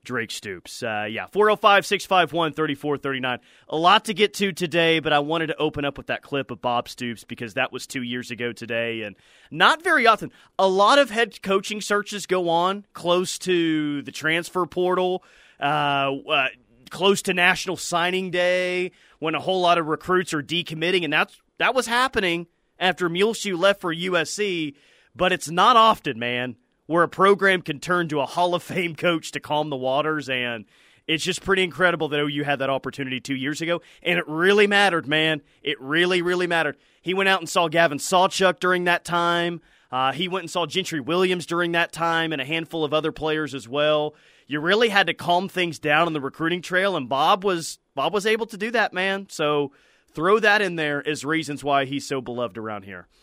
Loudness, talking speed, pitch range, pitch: -22 LUFS, 210 wpm, 145-185 Hz, 170 Hz